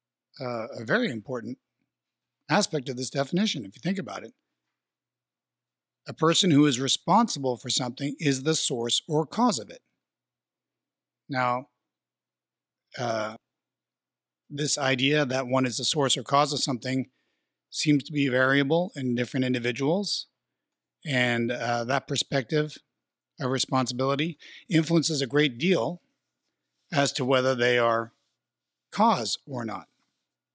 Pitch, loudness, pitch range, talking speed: 140 Hz, -25 LUFS, 125-150 Hz, 130 wpm